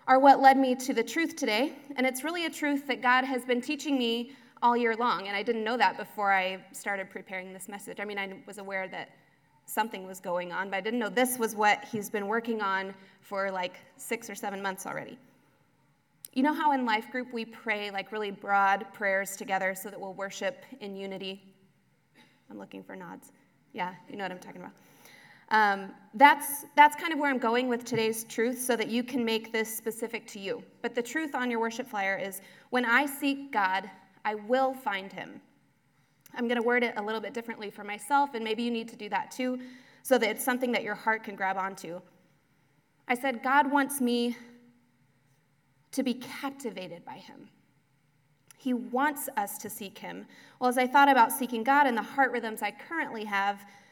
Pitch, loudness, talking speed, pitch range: 220 Hz, -29 LUFS, 205 wpm, 195-255 Hz